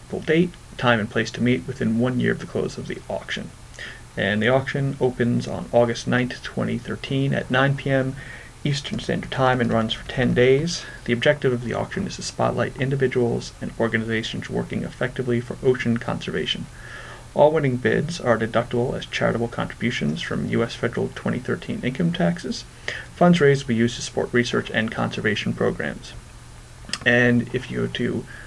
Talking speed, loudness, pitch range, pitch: 165 wpm, -23 LUFS, 120-135 Hz, 125 Hz